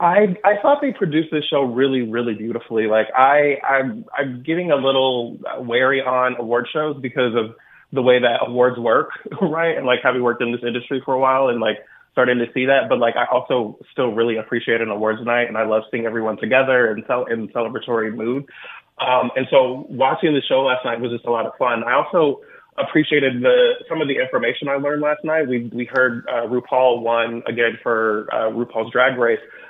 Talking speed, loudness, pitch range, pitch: 210 wpm, -19 LUFS, 120-150 Hz, 125 Hz